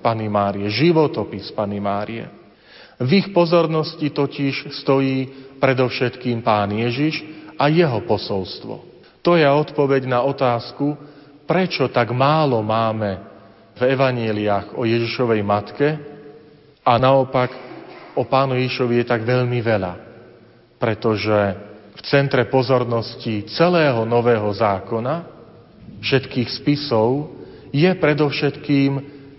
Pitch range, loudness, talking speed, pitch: 115-145 Hz, -19 LUFS, 100 wpm, 125 Hz